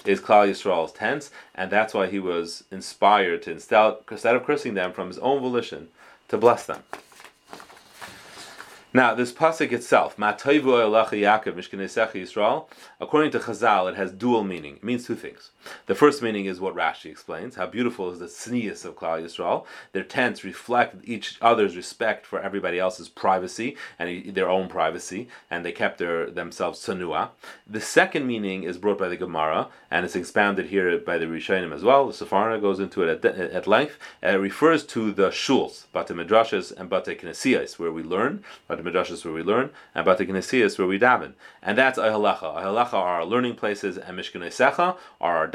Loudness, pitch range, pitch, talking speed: -24 LUFS, 90-120 Hz, 105 Hz, 180 wpm